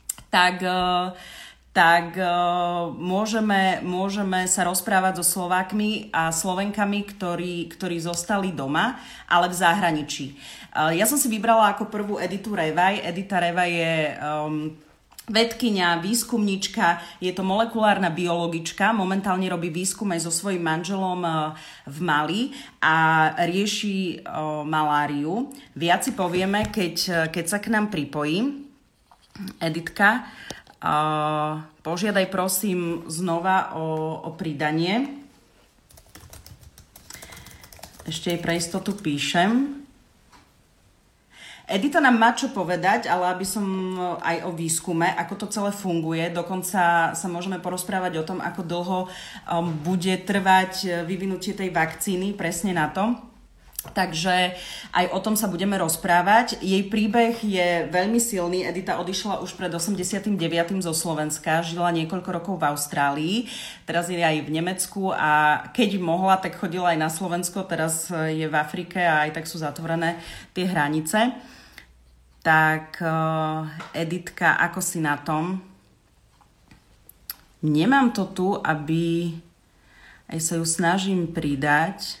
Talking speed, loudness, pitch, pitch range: 115 wpm, -23 LUFS, 180 Hz, 165-195 Hz